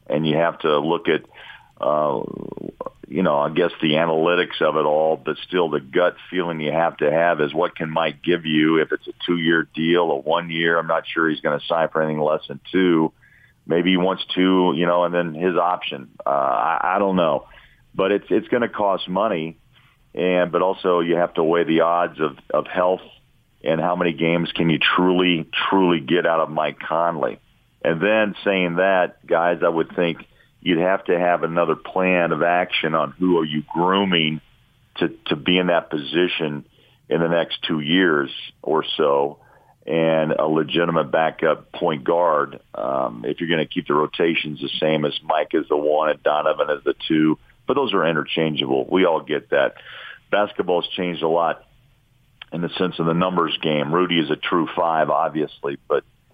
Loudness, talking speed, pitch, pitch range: -20 LUFS, 195 wpm, 85 Hz, 80-90 Hz